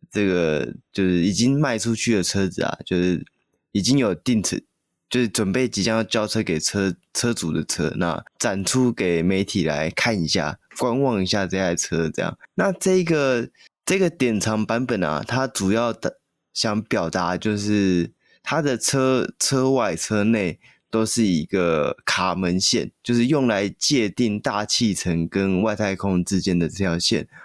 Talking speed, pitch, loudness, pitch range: 230 characters per minute, 105 Hz, -22 LUFS, 95-120 Hz